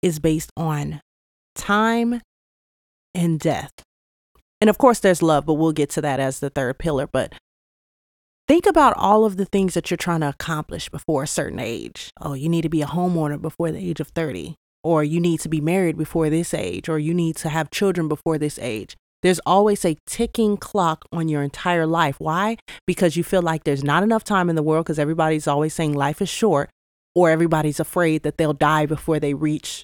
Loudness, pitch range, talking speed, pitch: -21 LUFS, 155-180 Hz, 205 wpm, 160 Hz